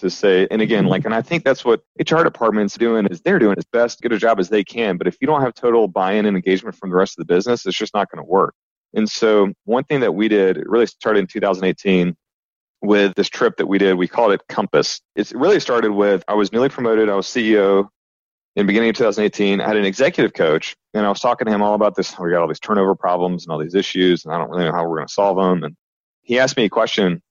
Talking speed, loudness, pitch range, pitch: 275 wpm, -18 LUFS, 95-110 Hz, 100 Hz